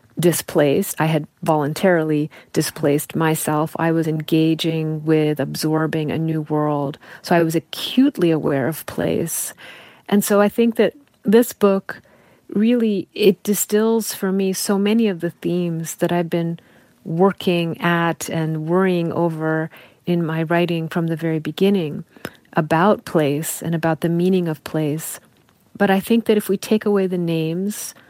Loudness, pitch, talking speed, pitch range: -19 LUFS, 170 Hz, 150 wpm, 160-195 Hz